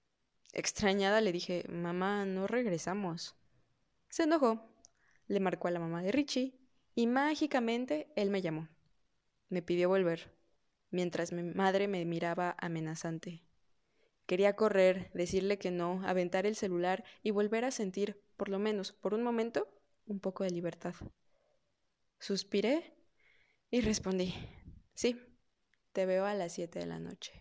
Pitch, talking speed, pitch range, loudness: 190 Hz, 140 wpm, 175-215 Hz, -35 LUFS